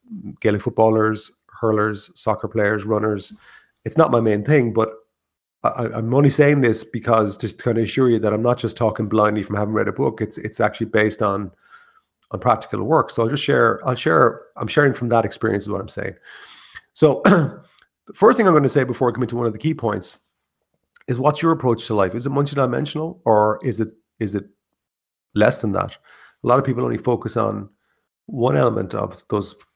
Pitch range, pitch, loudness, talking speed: 105-125 Hz, 115 Hz, -19 LUFS, 200 wpm